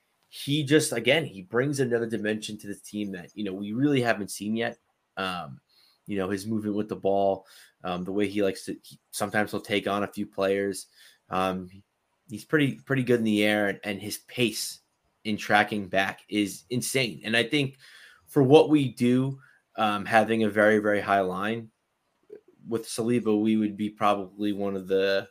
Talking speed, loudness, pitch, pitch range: 190 wpm, -26 LUFS, 105 Hz, 100-120 Hz